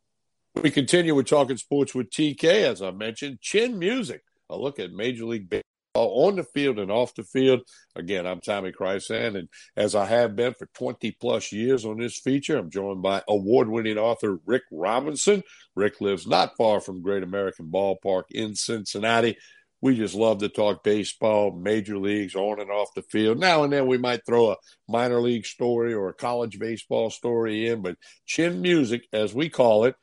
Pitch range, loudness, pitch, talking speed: 105-130 Hz, -24 LUFS, 115 Hz, 190 wpm